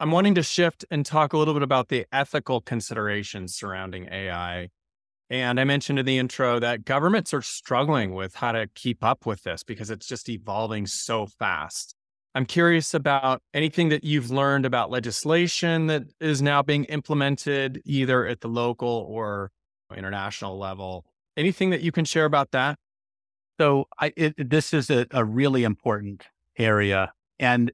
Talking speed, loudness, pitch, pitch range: 165 wpm, -24 LUFS, 130 Hz, 105-150 Hz